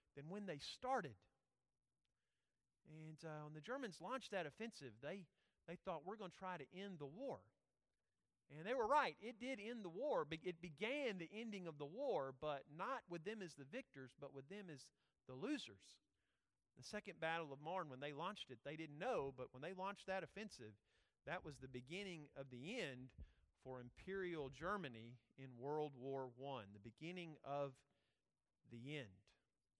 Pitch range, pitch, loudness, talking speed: 135-190 Hz, 155 Hz, -50 LUFS, 180 wpm